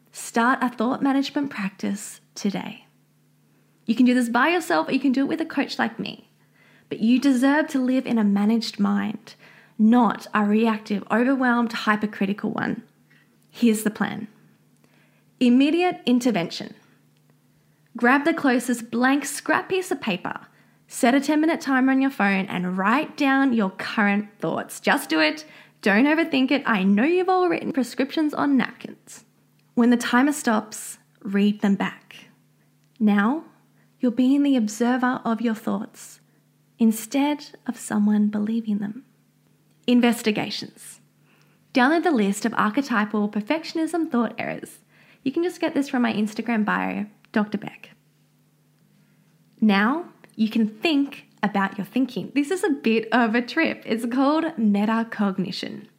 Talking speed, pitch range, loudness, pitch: 145 wpm, 210-275 Hz, -22 LUFS, 240 Hz